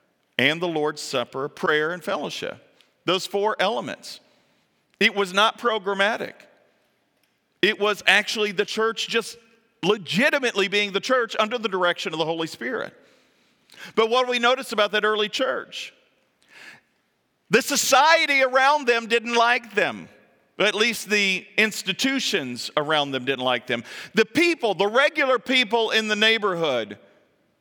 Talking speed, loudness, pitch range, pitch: 140 wpm, -22 LUFS, 185-235 Hz, 215 Hz